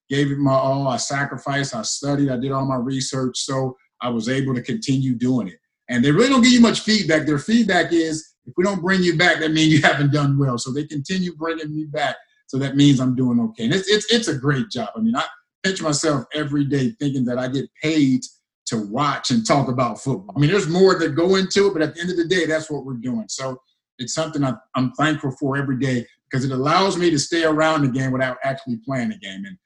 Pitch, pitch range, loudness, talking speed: 145 Hz, 130-175 Hz, -20 LUFS, 250 wpm